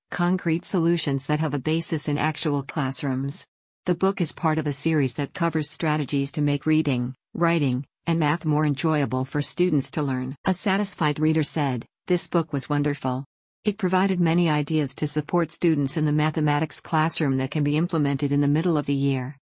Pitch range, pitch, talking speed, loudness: 145-165 Hz, 150 Hz, 185 wpm, -24 LUFS